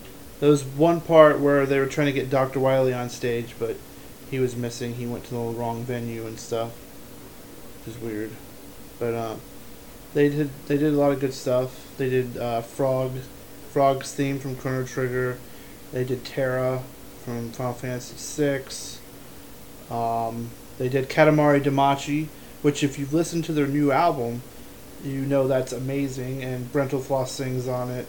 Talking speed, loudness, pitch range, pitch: 165 wpm, -24 LUFS, 120-140 Hz, 130 Hz